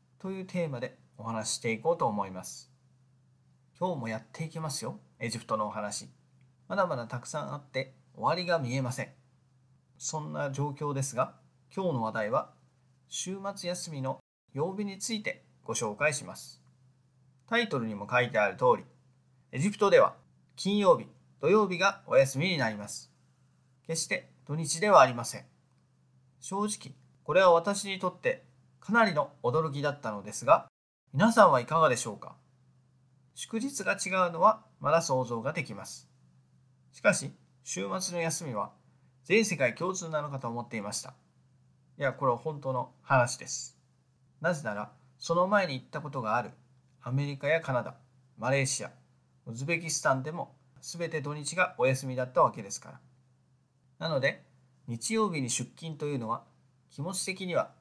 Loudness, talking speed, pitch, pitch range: -30 LUFS, 310 characters per minute, 135 Hz, 125-165 Hz